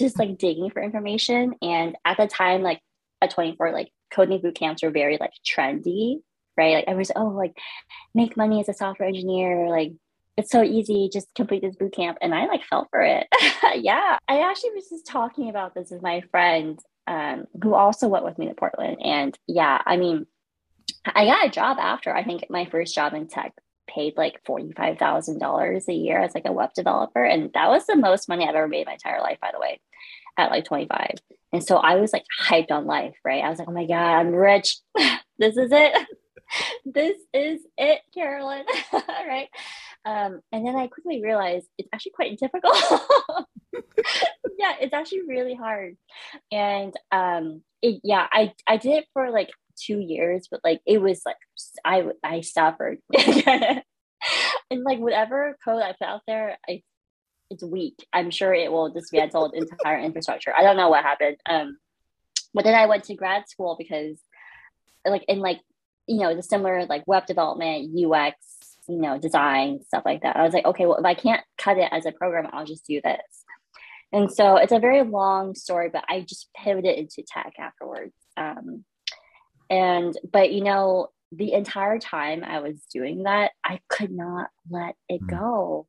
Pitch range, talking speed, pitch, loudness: 165-225 Hz, 190 wpm, 190 Hz, -23 LUFS